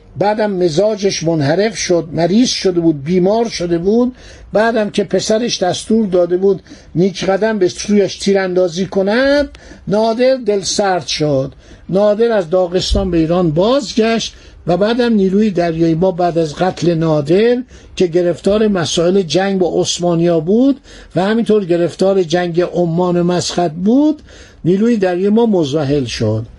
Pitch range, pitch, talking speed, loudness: 175-210 Hz, 185 Hz, 140 wpm, -14 LUFS